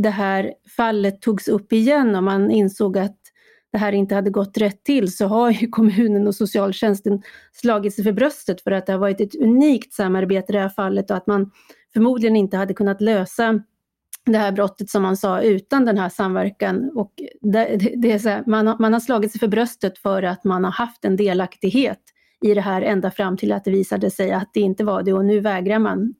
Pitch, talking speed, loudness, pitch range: 205 Hz, 215 wpm, -19 LUFS, 195-225 Hz